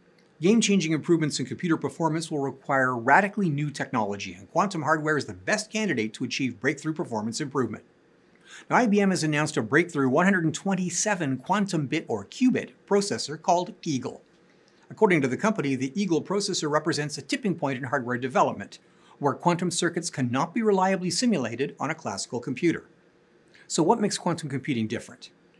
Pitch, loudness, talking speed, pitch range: 160 Hz, -26 LUFS, 155 wpm, 135-190 Hz